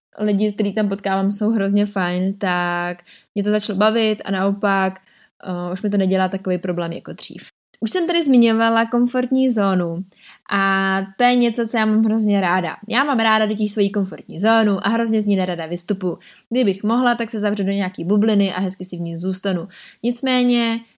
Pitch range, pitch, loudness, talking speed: 190-225 Hz, 205 Hz, -19 LUFS, 190 wpm